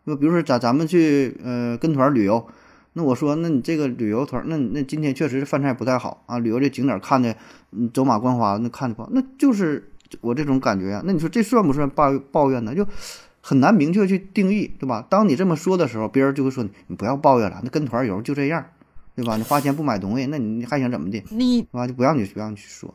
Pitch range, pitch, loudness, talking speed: 120-160 Hz, 140 Hz, -21 LUFS, 360 characters per minute